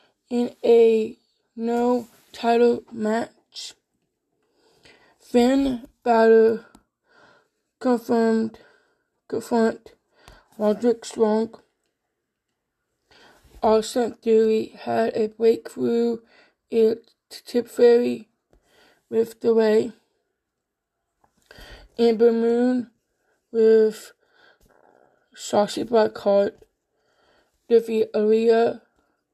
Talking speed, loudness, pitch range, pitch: 60 wpm, -21 LUFS, 220-245 Hz, 230 Hz